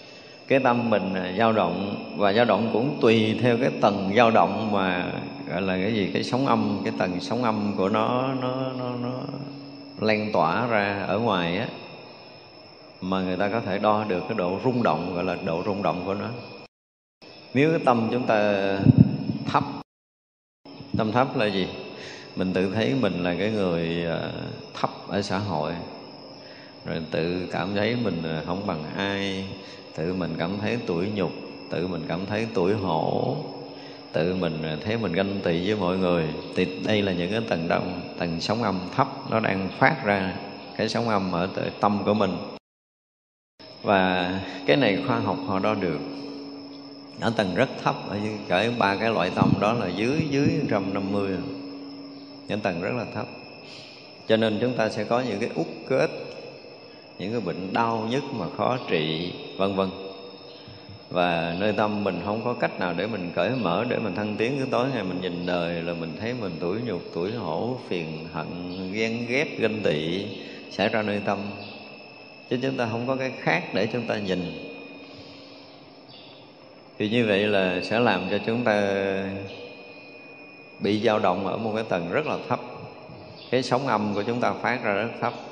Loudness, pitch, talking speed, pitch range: -25 LUFS, 100 Hz, 180 wpm, 90-115 Hz